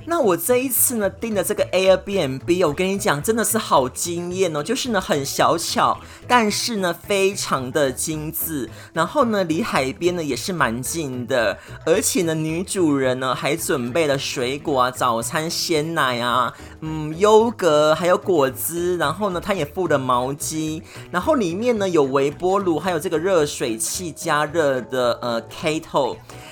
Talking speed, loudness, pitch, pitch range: 250 characters per minute, -20 LUFS, 170 Hz, 140-195 Hz